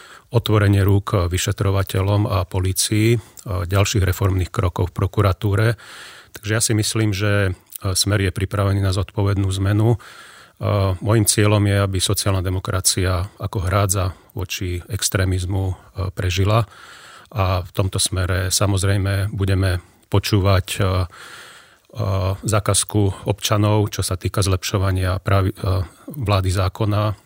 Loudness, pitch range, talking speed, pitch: -20 LUFS, 95-105 Hz, 105 wpm, 100 Hz